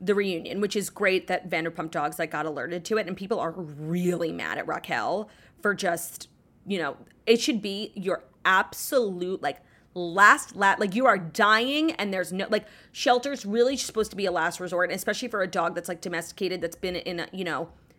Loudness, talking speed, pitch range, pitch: -26 LUFS, 205 wpm, 175-210 Hz, 185 Hz